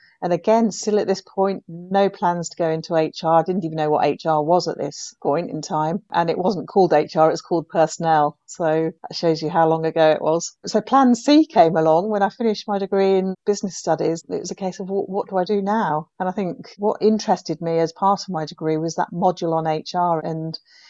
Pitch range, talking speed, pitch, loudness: 160-195 Hz, 235 wpm, 175 Hz, -20 LUFS